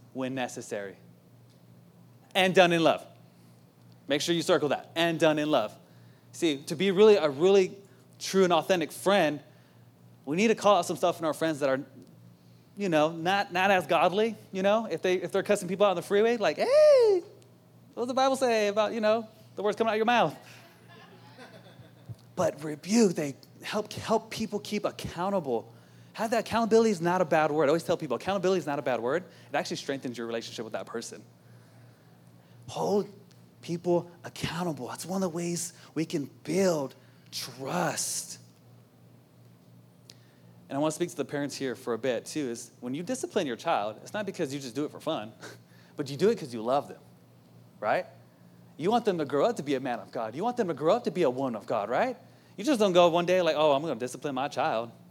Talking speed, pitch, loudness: 210 wpm, 160 Hz, -28 LUFS